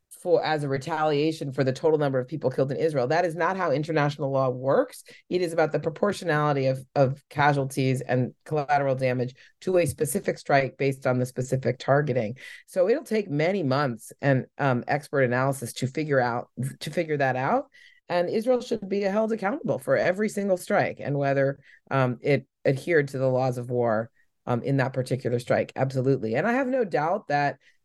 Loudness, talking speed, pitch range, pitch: -26 LUFS, 185 wpm, 130-165 Hz, 140 Hz